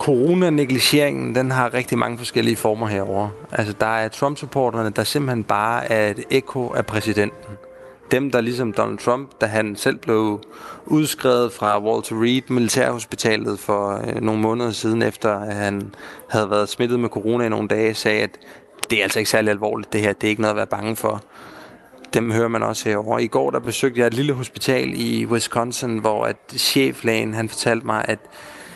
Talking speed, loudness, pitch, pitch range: 185 wpm, -20 LUFS, 115 Hz, 105-125 Hz